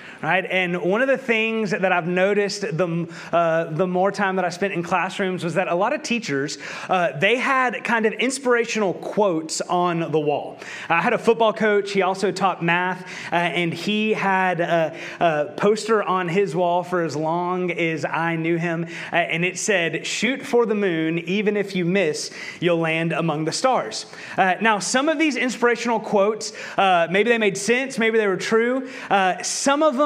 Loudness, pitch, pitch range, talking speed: -21 LUFS, 190 Hz, 170-220 Hz, 195 wpm